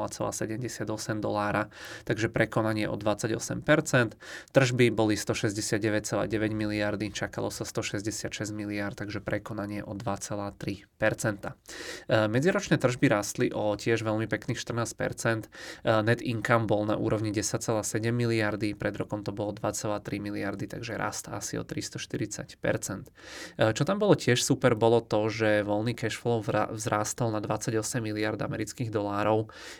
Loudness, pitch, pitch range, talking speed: -29 LUFS, 110 Hz, 105-115 Hz, 120 wpm